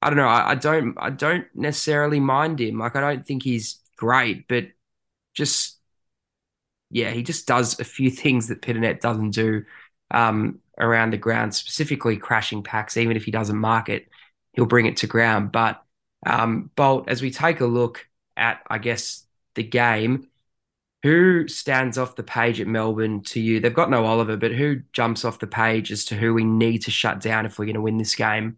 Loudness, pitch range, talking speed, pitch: -21 LUFS, 110-130 Hz, 200 wpm, 115 Hz